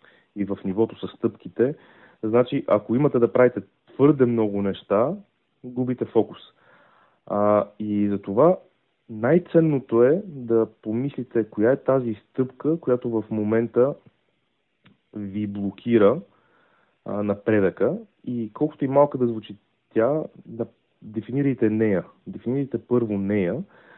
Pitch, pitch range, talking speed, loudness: 115 Hz, 105-130 Hz, 115 wpm, -23 LUFS